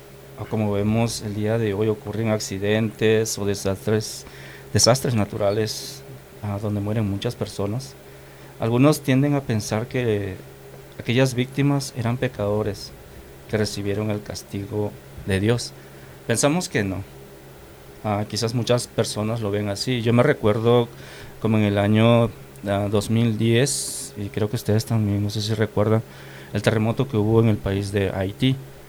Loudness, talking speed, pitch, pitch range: -22 LUFS, 140 wpm, 105 Hz, 100-115 Hz